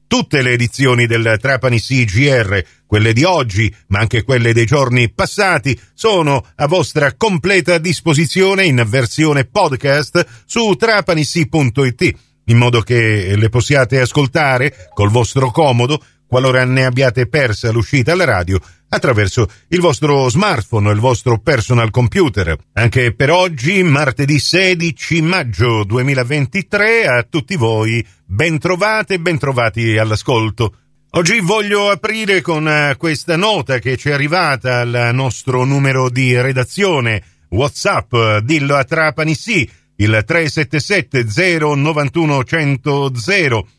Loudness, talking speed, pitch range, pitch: -14 LUFS, 120 wpm, 115-160 Hz, 135 Hz